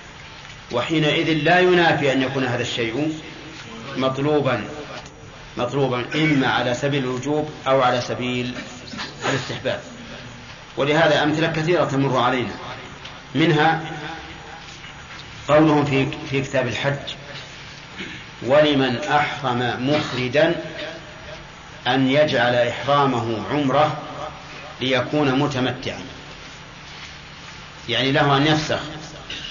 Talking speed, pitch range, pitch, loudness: 85 wpm, 125-150 Hz, 145 Hz, -20 LUFS